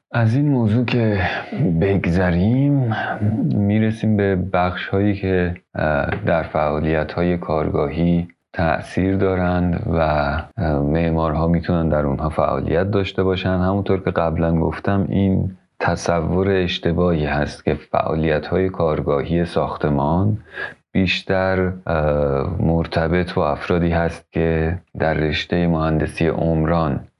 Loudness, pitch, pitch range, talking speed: -19 LUFS, 85 Hz, 80-95 Hz, 105 wpm